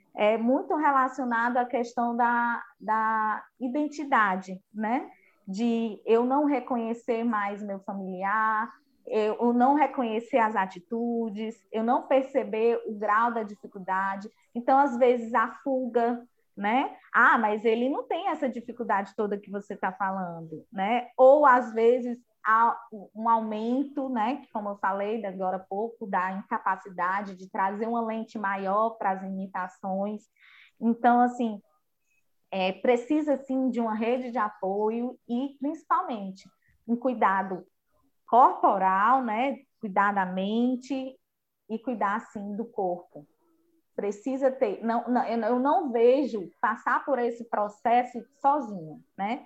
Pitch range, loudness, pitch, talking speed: 205-255 Hz, -27 LUFS, 230 Hz, 130 wpm